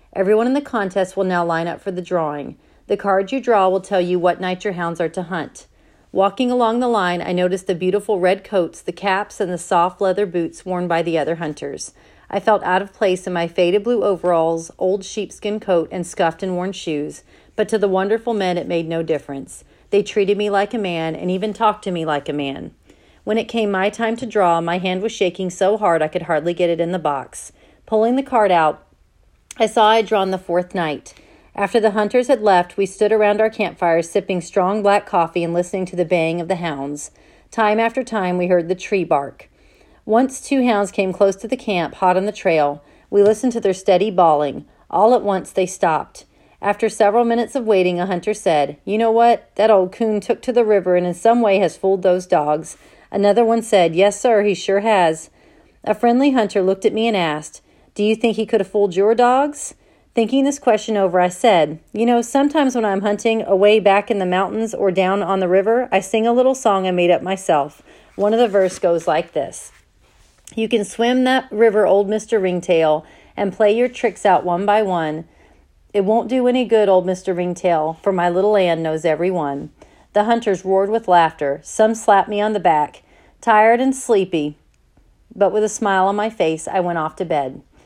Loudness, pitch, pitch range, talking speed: -18 LUFS, 195 Hz, 175-220 Hz, 220 wpm